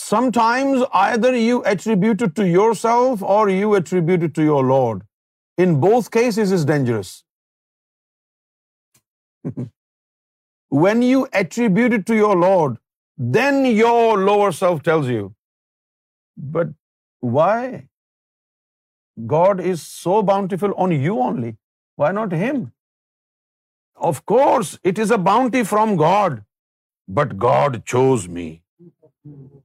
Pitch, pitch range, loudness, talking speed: 195 Hz, 155-230 Hz, -17 LUFS, 115 wpm